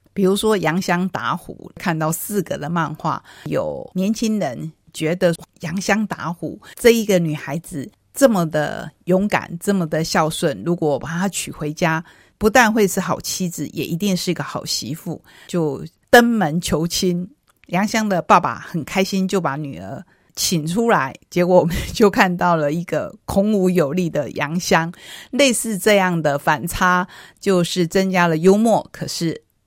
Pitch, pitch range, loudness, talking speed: 175 Hz, 160-195 Hz, -19 LUFS, 235 characters per minute